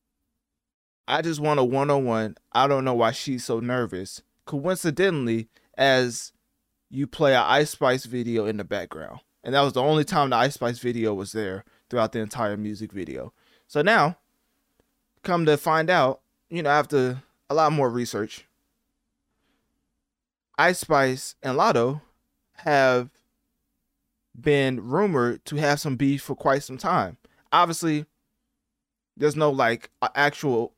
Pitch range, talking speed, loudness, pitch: 120-150 Hz, 140 wpm, -24 LUFS, 135 Hz